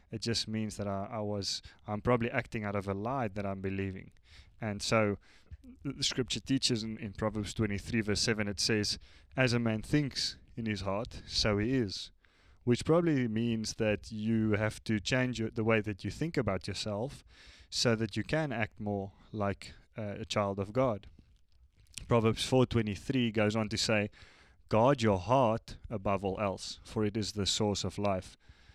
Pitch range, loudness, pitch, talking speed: 100-115 Hz, -33 LUFS, 105 Hz, 180 wpm